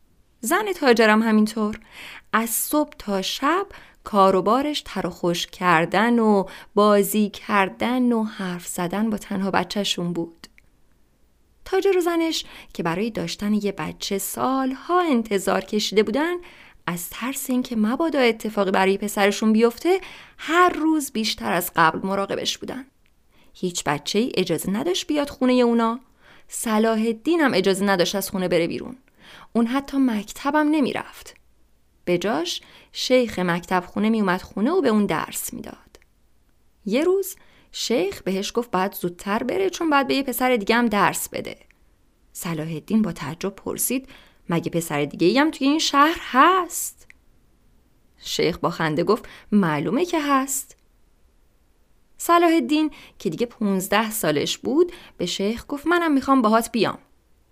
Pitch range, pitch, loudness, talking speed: 190-275 Hz, 220 Hz, -22 LUFS, 140 wpm